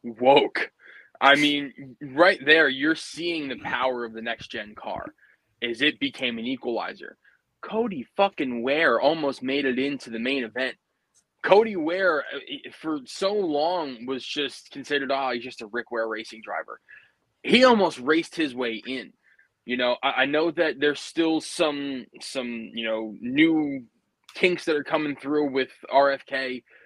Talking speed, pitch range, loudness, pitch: 160 wpm, 125-195 Hz, -24 LUFS, 140 Hz